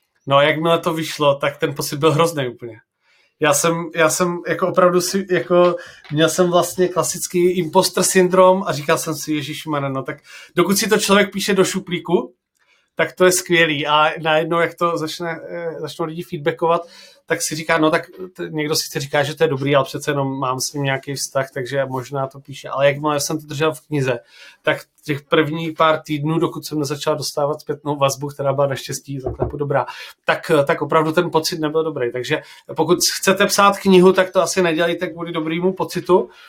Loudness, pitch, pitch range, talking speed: -18 LUFS, 160 Hz, 150-175 Hz, 195 wpm